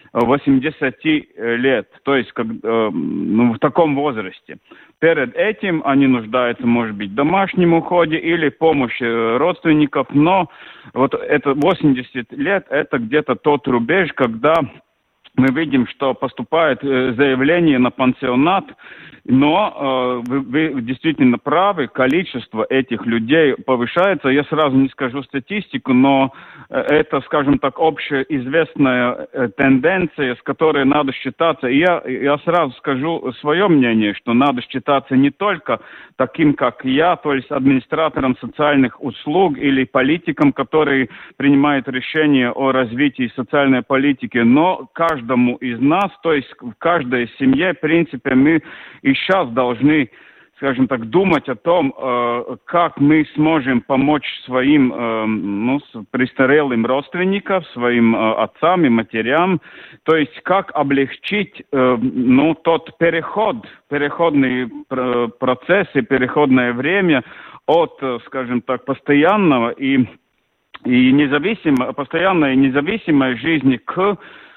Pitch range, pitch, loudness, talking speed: 130-160 Hz, 140 Hz, -17 LUFS, 125 wpm